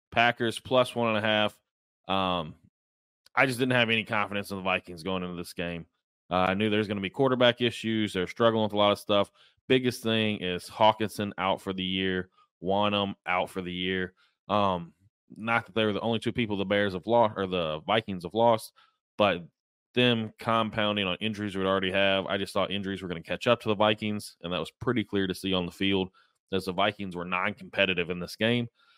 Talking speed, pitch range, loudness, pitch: 220 wpm, 95-110 Hz, -28 LUFS, 100 Hz